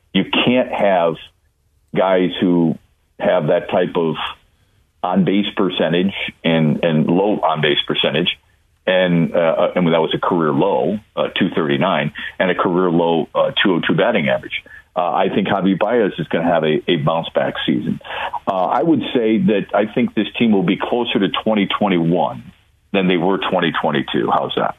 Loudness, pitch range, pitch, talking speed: -17 LUFS, 85-100 Hz, 95 Hz, 170 wpm